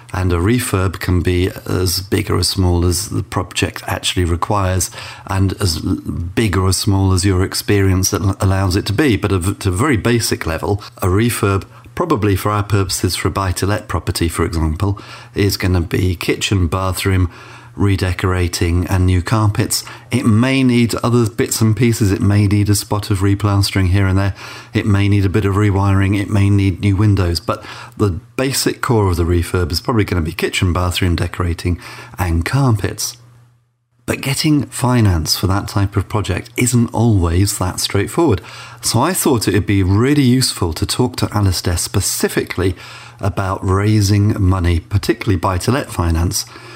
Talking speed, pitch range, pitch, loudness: 175 wpm, 95-115 Hz, 100 Hz, -16 LUFS